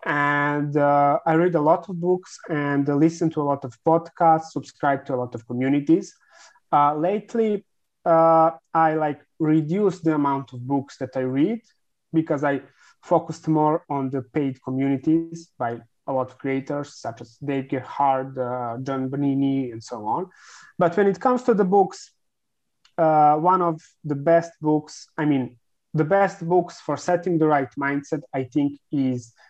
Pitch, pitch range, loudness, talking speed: 150 Hz, 135-170 Hz, -22 LUFS, 170 wpm